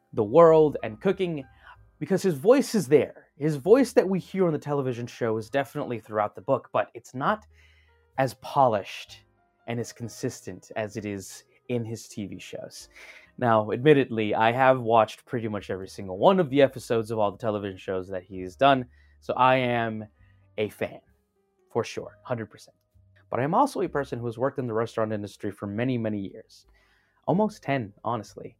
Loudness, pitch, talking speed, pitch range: -26 LUFS, 115 Hz, 180 wpm, 105-145 Hz